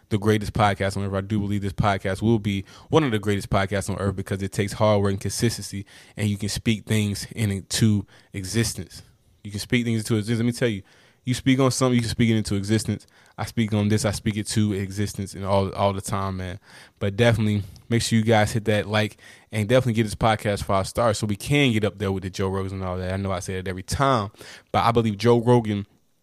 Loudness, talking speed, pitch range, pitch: -23 LUFS, 250 wpm, 100-115 Hz, 105 Hz